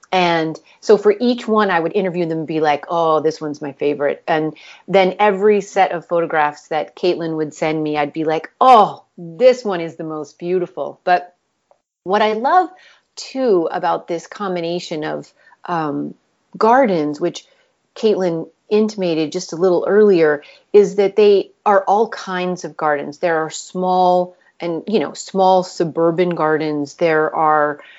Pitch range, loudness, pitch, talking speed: 160-200 Hz, -17 LUFS, 175 Hz, 160 wpm